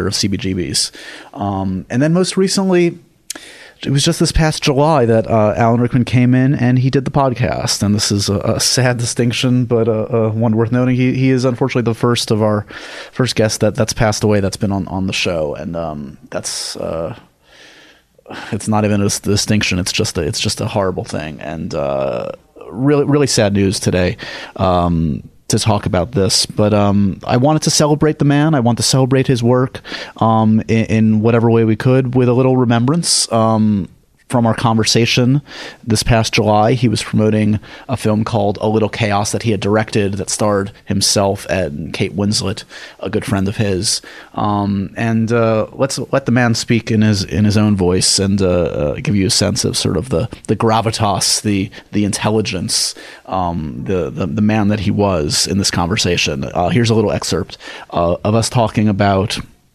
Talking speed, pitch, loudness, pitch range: 195 wpm, 110 Hz, -15 LUFS, 100-125 Hz